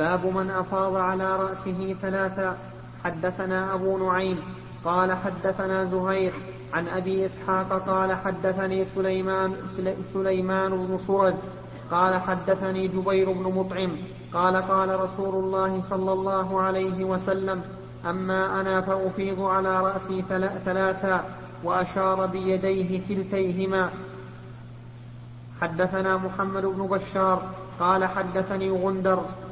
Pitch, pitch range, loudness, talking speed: 190 Hz, 185-190 Hz, -26 LUFS, 100 wpm